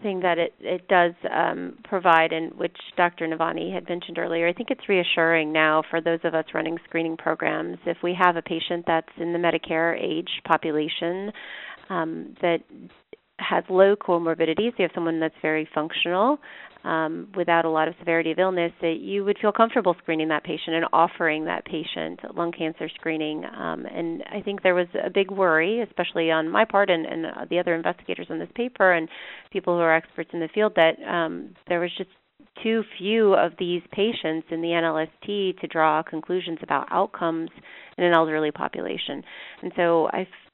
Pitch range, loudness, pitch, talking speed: 160-185 Hz, -24 LUFS, 170 Hz, 185 wpm